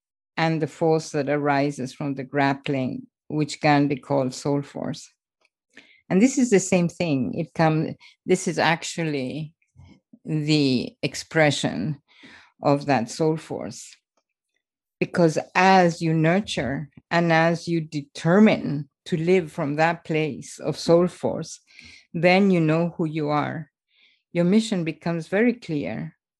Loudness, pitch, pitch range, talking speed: -23 LUFS, 160 Hz, 145-175 Hz, 130 wpm